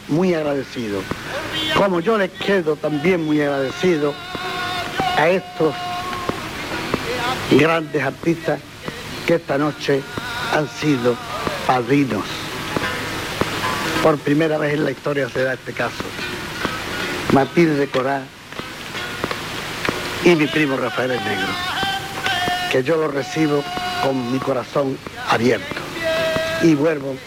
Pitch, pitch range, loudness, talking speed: 150 Hz, 135-175 Hz, -20 LUFS, 105 wpm